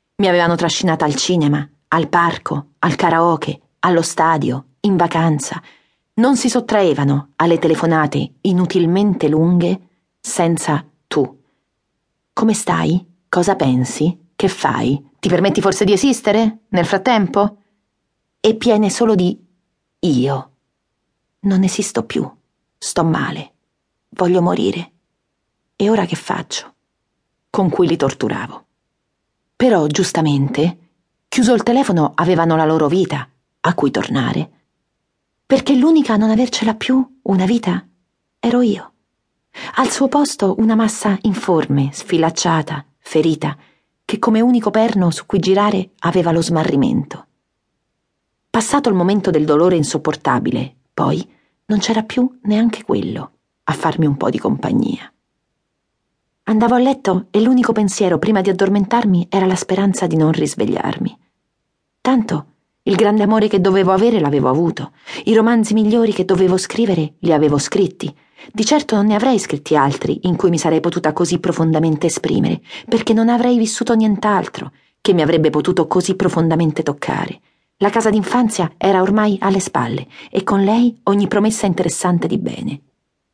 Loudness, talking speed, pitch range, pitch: -16 LUFS, 135 wpm, 160-215 Hz, 185 Hz